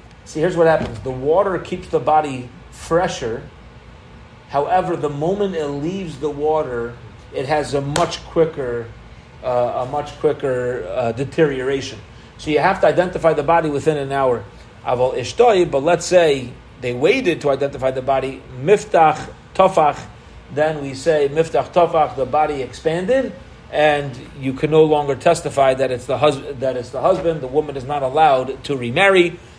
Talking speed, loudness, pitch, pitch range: 160 wpm, -18 LUFS, 145 Hz, 130-160 Hz